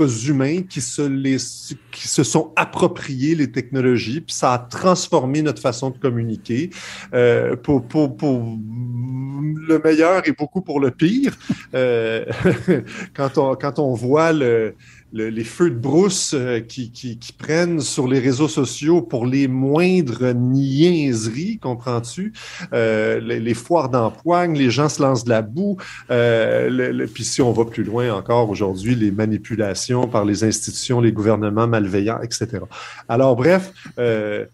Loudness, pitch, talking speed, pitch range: -19 LUFS, 130 Hz, 155 wpm, 115-155 Hz